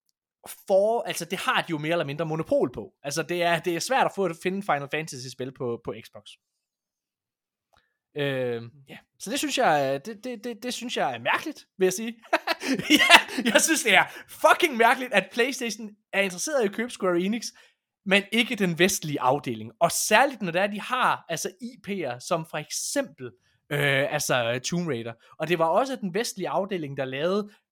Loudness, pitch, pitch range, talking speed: -25 LUFS, 185 Hz, 150-235 Hz, 195 wpm